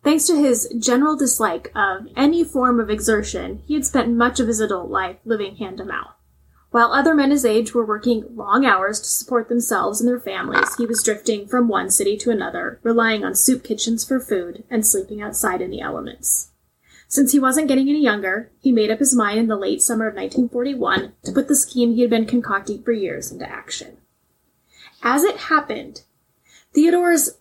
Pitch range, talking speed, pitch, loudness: 215-275 Hz, 195 wpm, 240 Hz, -19 LUFS